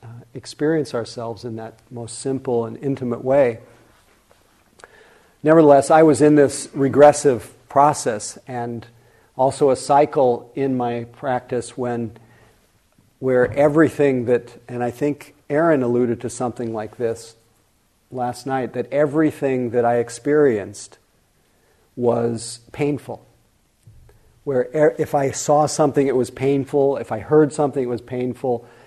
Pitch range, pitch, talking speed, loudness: 120-145 Hz, 125 Hz, 130 wpm, -19 LUFS